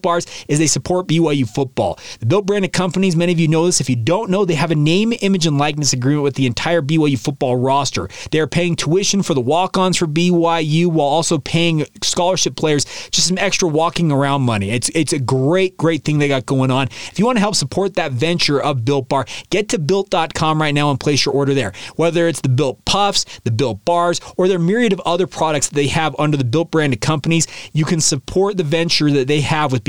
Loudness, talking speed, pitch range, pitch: -16 LUFS, 235 wpm, 140-175 Hz, 160 Hz